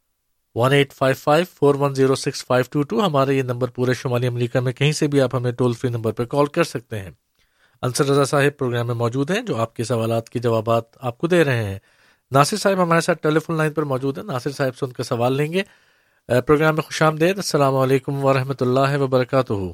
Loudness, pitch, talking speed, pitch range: -20 LUFS, 135 Hz, 230 wpm, 125-150 Hz